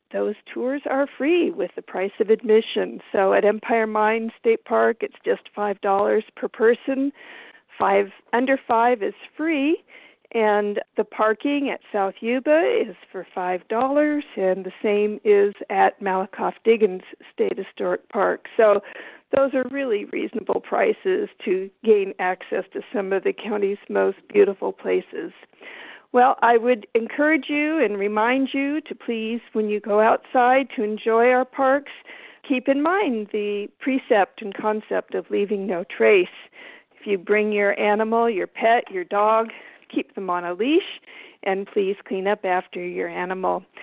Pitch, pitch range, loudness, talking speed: 225 Hz, 205-285 Hz, -22 LUFS, 155 wpm